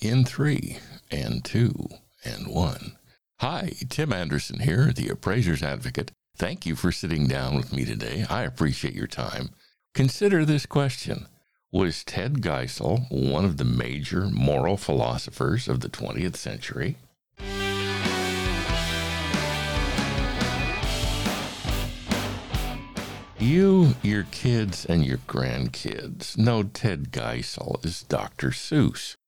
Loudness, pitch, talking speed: -26 LUFS, 95 Hz, 110 wpm